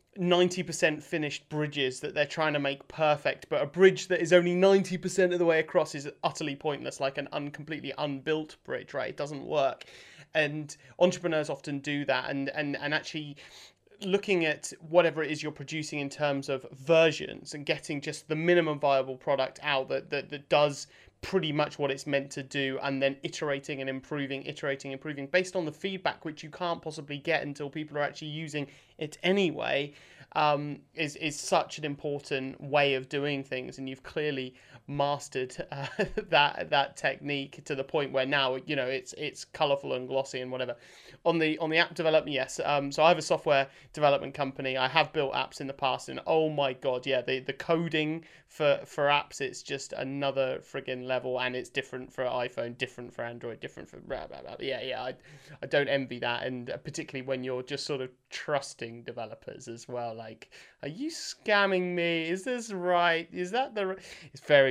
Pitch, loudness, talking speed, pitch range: 145 Hz, -30 LUFS, 195 wpm, 135-160 Hz